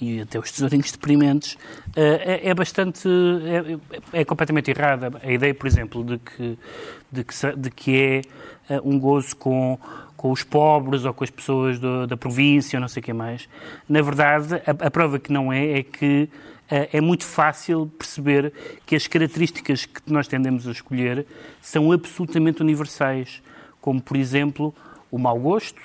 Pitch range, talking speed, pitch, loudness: 130-155 Hz, 165 wpm, 140 Hz, -22 LUFS